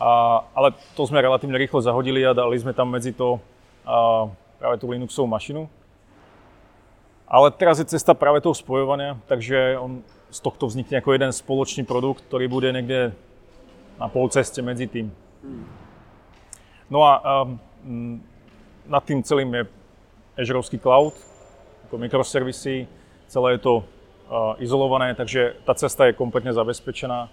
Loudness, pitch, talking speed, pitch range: -21 LUFS, 125 Hz, 135 wpm, 115-135 Hz